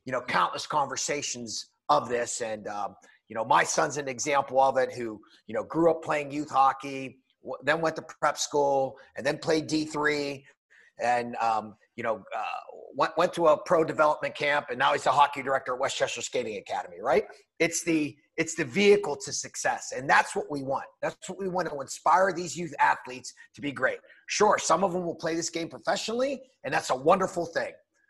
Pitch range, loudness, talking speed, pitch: 135-180 Hz, -27 LUFS, 205 wpm, 155 Hz